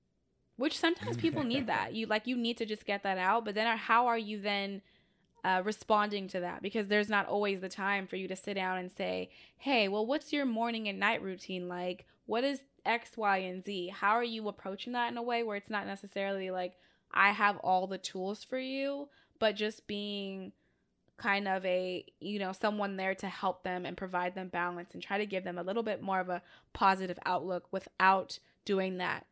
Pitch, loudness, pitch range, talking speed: 200 Hz, -34 LUFS, 185-225 Hz, 215 wpm